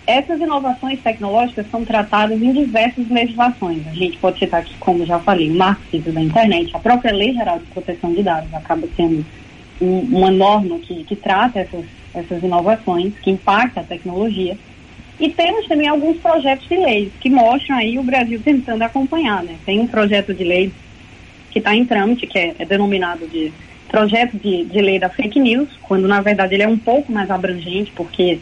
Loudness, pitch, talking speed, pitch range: -16 LUFS, 205 Hz, 185 wpm, 180-240 Hz